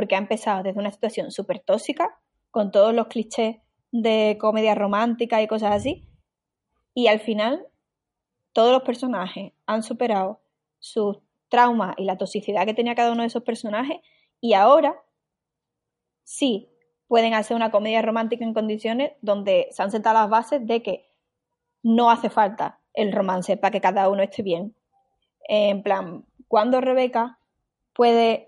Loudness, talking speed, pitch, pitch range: -22 LUFS, 150 wpm, 225 Hz, 205-240 Hz